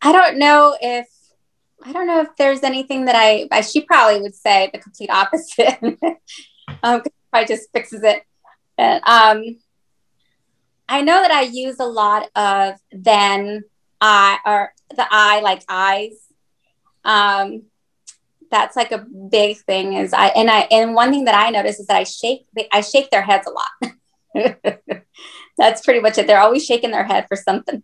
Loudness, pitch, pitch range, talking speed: -15 LUFS, 225 Hz, 205-265 Hz, 170 wpm